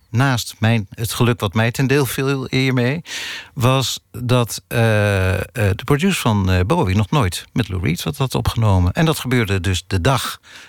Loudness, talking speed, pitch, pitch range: -18 LUFS, 175 wpm, 115 Hz, 100-130 Hz